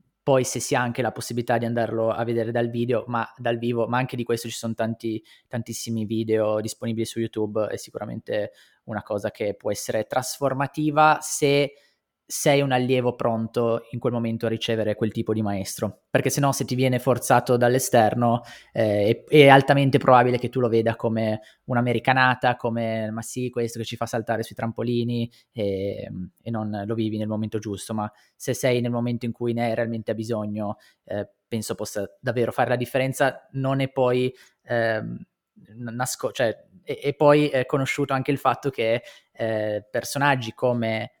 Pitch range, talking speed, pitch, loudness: 115-130 Hz, 180 wpm, 120 Hz, -24 LUFS